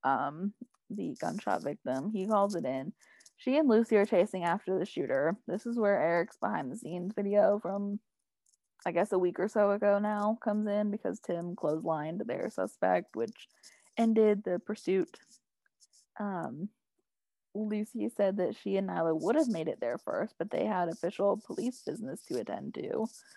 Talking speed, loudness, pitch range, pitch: 165 wpm, -32 LUFS, 180-220 Hz, 205 Hz